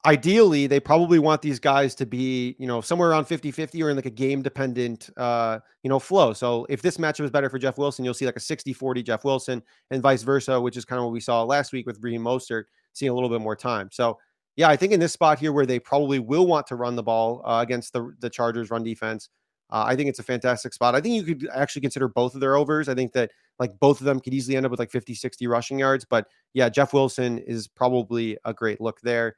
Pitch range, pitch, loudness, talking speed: 120-140 Hz, 130 Hz, -24 LUFS, 265 wpm